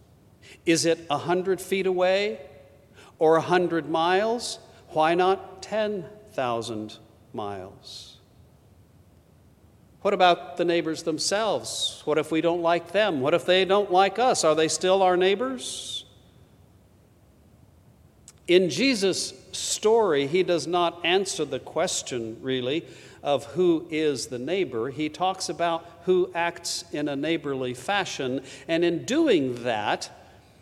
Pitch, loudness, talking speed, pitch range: 165 Hz, -25 LUFS, 125 wpm, 130-185 Hz